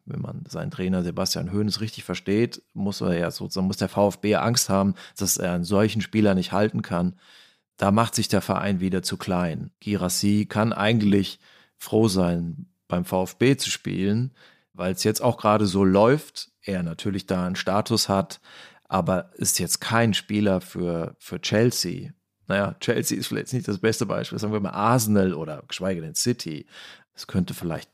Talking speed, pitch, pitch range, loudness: 175 wpm, 100 Hz, 95-110 Hz, -24 LUFS